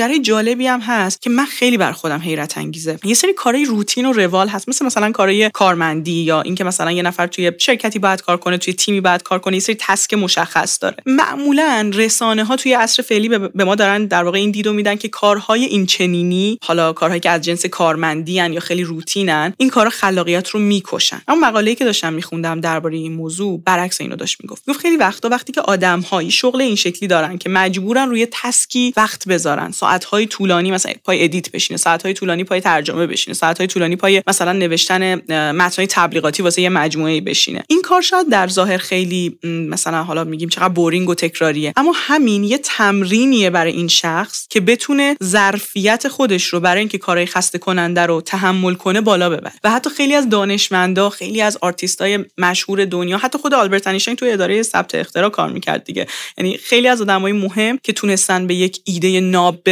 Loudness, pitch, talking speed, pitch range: -15 LUFS, 190 Hz, 200 wpm, 175-220 Hz